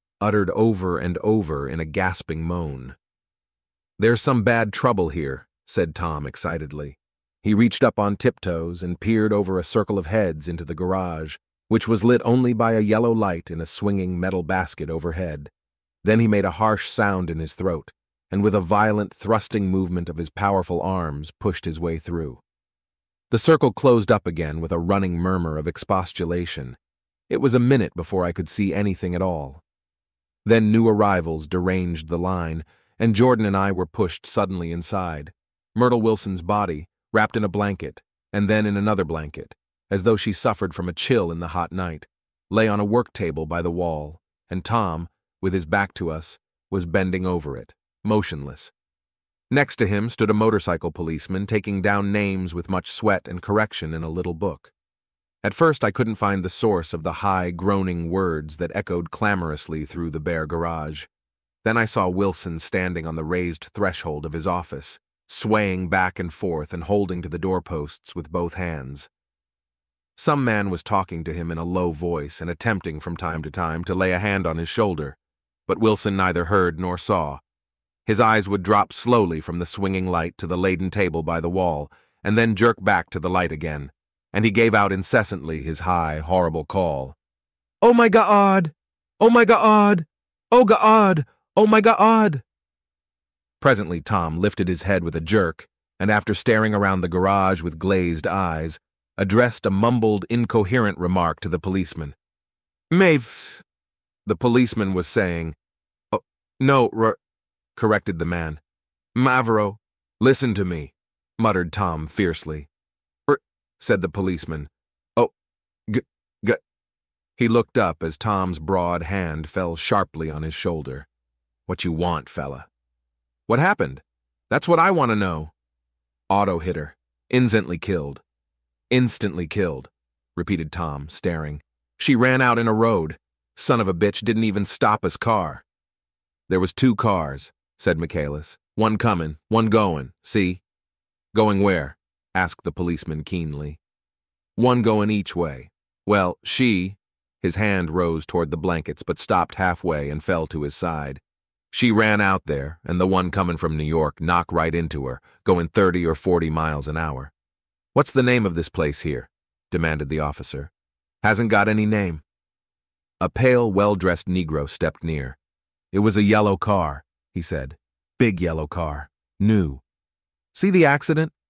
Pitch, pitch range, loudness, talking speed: 90 Hz, 75-105 Hz, -22 LUFS, 165 wpm